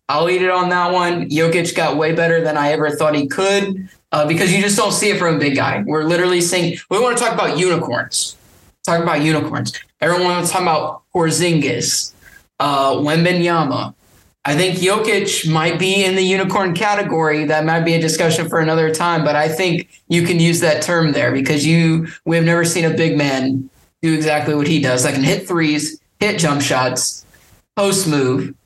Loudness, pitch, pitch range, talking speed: -16 LUFS, 165 Hz, 150-180 Hz, 200 wpm